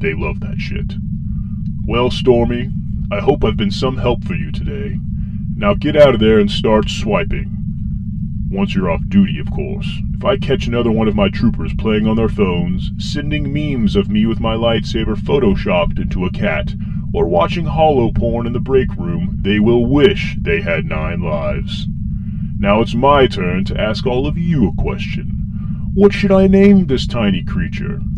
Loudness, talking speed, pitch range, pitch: -16 LUFS, 180 wpm, 105-130 Hz, 115 Hz